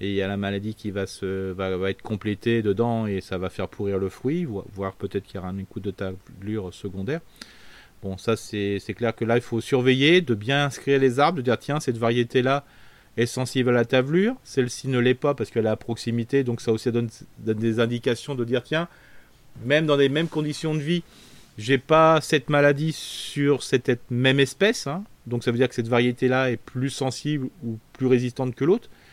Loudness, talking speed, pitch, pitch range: -24 LUFS, 225 wpm, 120 Hz, 110-140 Hz